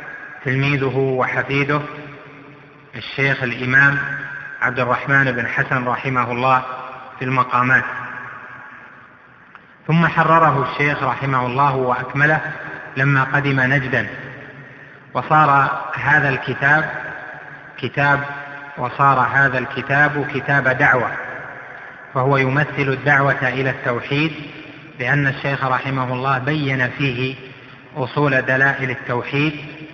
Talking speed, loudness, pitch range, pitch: 90 wpm, -18 LUFS, 125-145 Hz, 135 Hz